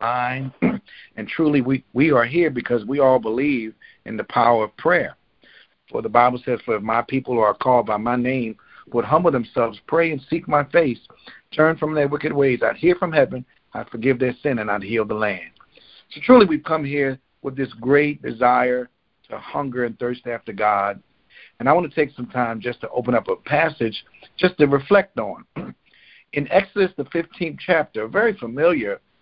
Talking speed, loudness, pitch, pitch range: 195 wpm, -20 LUFS, 135 Hz, 120-155 Hz